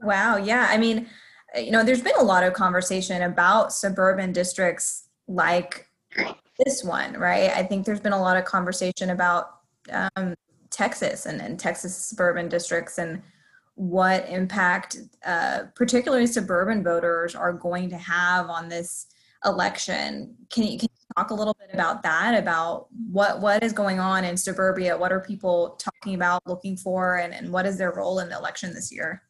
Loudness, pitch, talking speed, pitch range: -24 LUFS, 185 Hz, 175 wpm, 175-205 Hz